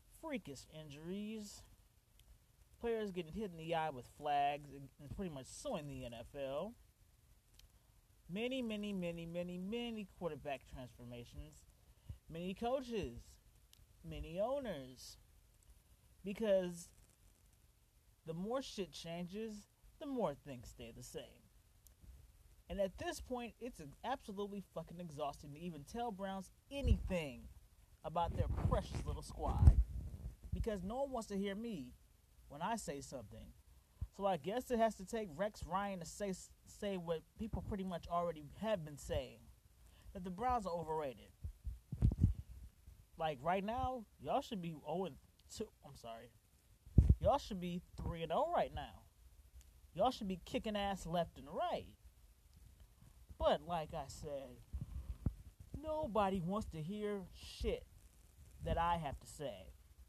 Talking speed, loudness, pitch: 135 wpm, -42 LUFS, 165 Hz